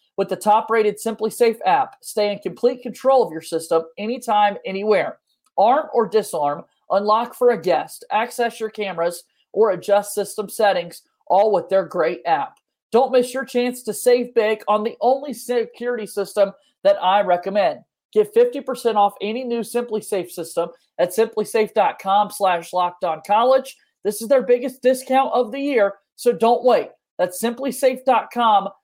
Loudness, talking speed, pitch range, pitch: -20 LUFS, 155 wpm, 200-250 Hz, 225 Hz